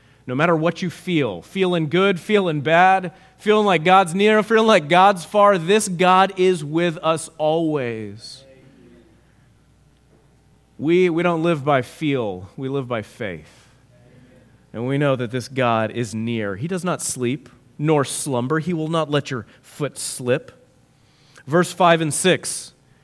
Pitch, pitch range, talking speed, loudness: 155 Hz, 125-180 Hz, 150 wpm, -19 LUFS